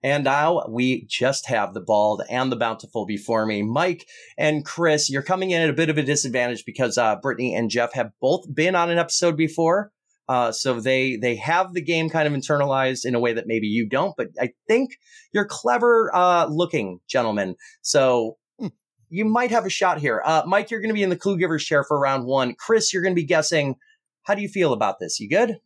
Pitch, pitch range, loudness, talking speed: 150 Hz, 125-185 Hz, -22 LUFS, 225 wpm